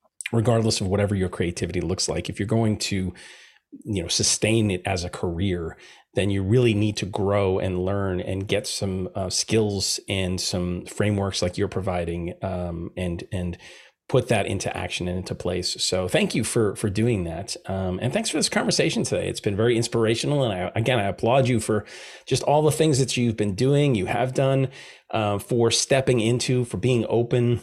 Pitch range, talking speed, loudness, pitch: 90-115 Hz, 195 wpm, -24 LUFS, 105 Hz